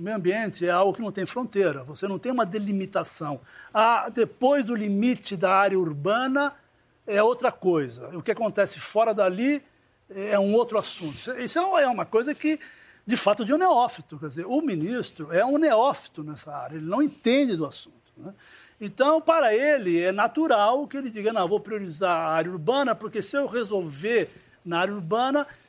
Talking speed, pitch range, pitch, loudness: 185 wpm, 185-260 Hz, 215 Hz, -24 LUFS